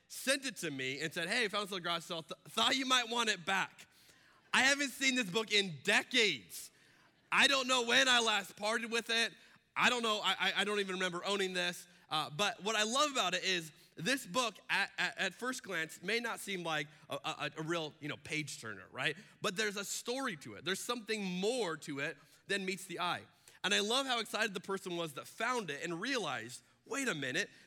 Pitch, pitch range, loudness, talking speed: 195 Hz, 170-230 Hz, -34 LUFS, 220 wpm